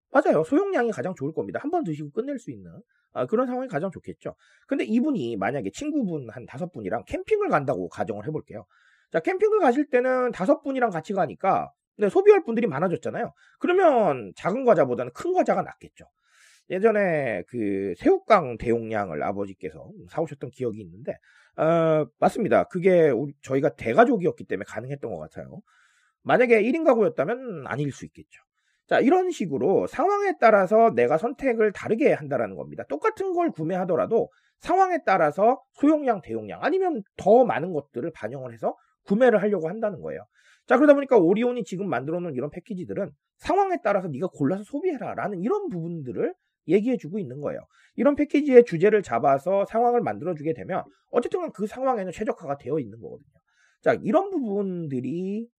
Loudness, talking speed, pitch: -24 LUFS, 390 characters per minute, 215 Hz